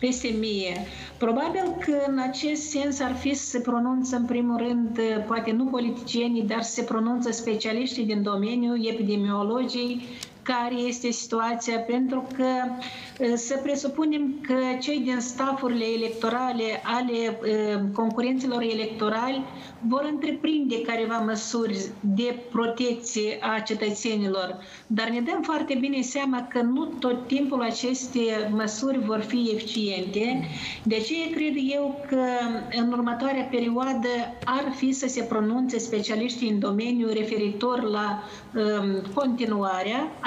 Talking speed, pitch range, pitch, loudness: 125 wpm, 220-255 Hz, 240 Hz, -26 LUFS